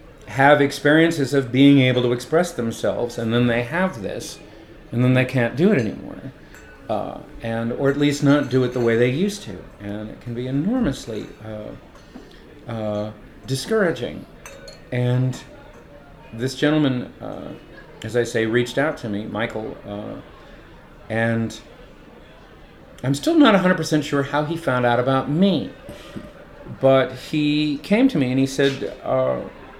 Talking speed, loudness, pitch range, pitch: 150 wpm, -20 LUFS, 115-145 Hz, 130 Hz